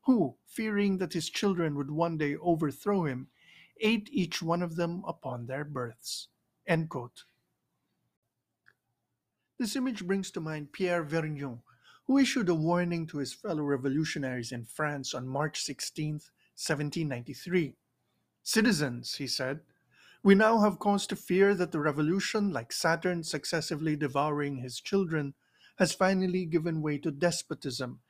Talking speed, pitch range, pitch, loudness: 140 wpm, 145-185 Hz, 165 Hz, -31 LUFS